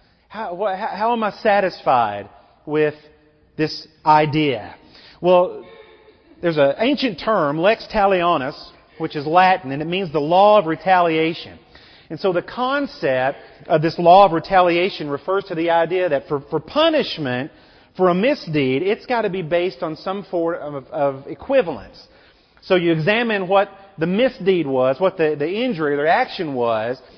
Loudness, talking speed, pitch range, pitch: -19 LUFS, 160 wpm, 150-200 Hz, 175 Hz